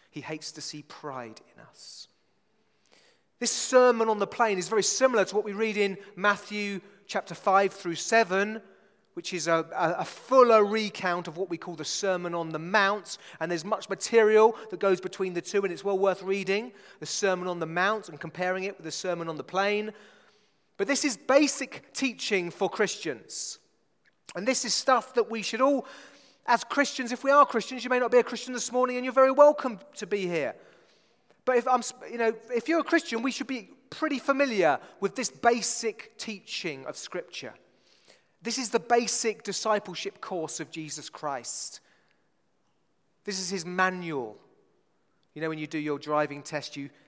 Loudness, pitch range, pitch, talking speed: -27 LUFS, 180-245 Hz, 210 Hz, 185 wpm